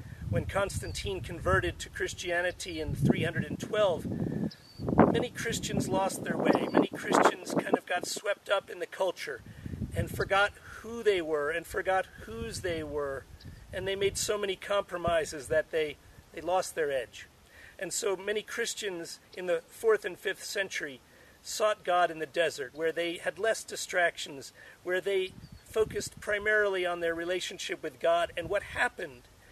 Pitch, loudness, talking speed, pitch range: 185 Hz, -31 LUFS, 155 wpm, 170-210 Hz